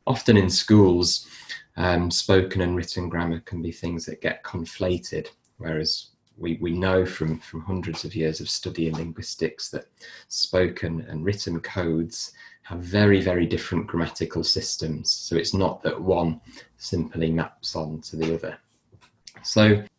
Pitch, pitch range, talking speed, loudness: 85 Hz, 80-95 Hz, 150 wpm, -24 LUFS